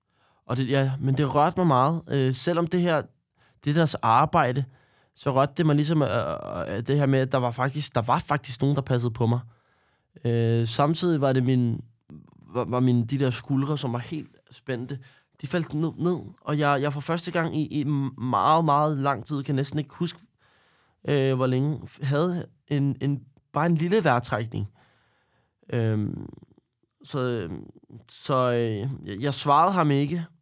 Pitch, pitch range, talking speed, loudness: 140 Hz, 125-150 Hz, 175 wpm, -25 LUFS